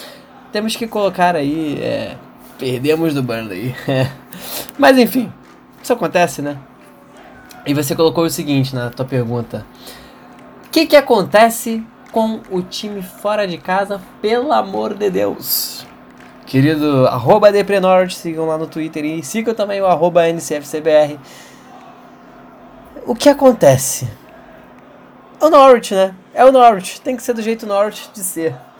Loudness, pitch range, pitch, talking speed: -15 LUFS, 150-225 Hz, 185 Hz, 140 wpm